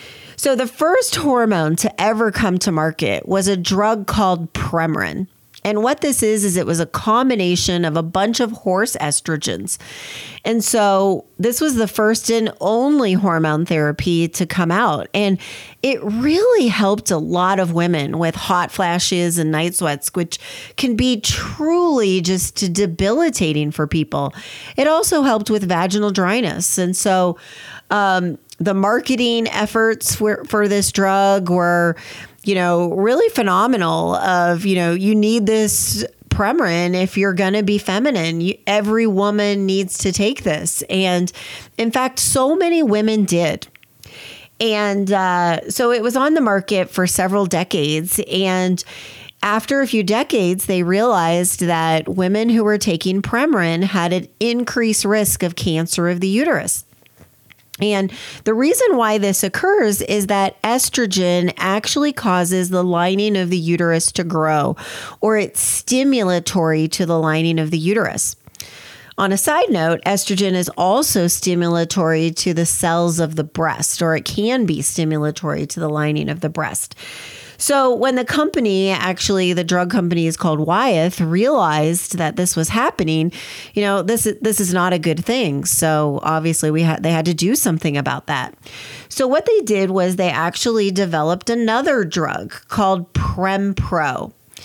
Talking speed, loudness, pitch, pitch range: 155 wpm, -17 LUFS, 190 Hz, 170-220 Hz